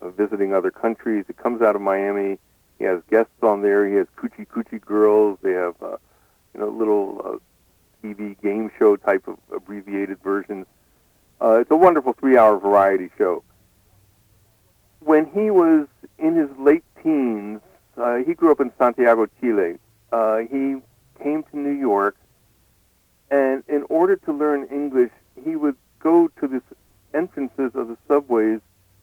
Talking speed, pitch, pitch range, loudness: 155 wpm, 110 Hz, 100-145 Hz, -20 LUFS